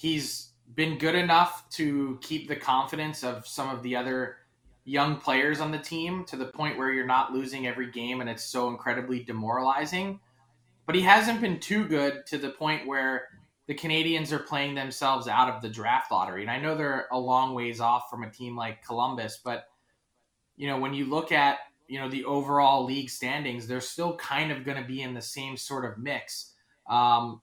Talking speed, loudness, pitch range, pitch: 200 wpm, -28 LUFS, 125-150 Hz, 135 Hz